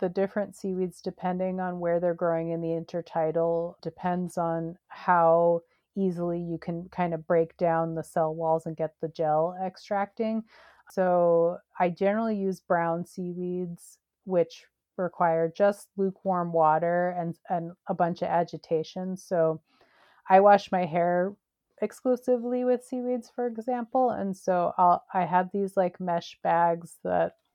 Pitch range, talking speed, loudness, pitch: 170-195 Hz, 145 wpm, -27 LUFS, 180 Hz